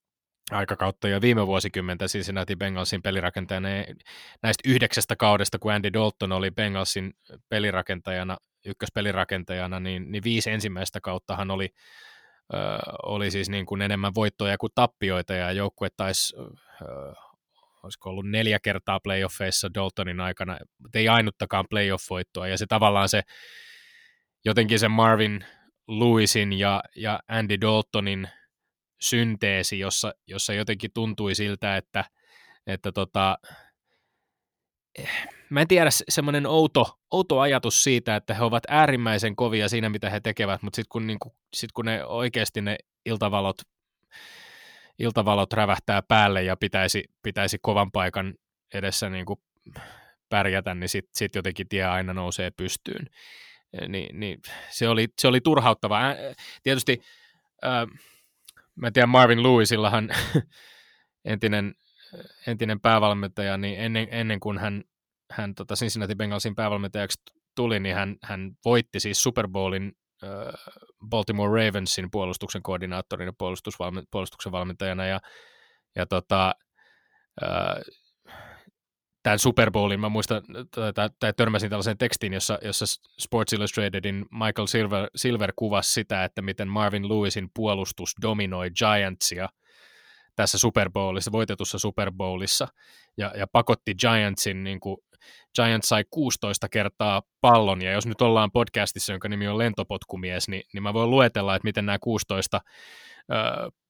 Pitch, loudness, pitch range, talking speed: 105 Hz, -25 LUFS, 95-115 Hz, 125 wpm